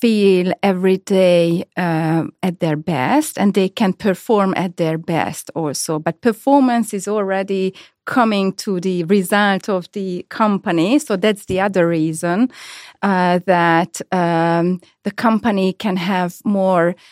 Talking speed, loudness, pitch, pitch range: 135 wpm, -17 LUFS, 190 Hz, 175-205 Hz